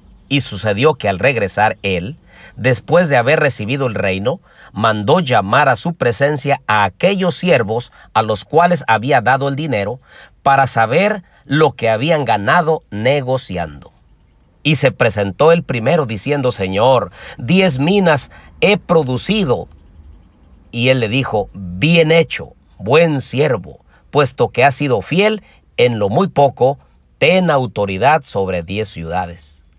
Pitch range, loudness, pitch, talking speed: 100-155 Hz, -15 LUFS, 130 Hz, 135 wpm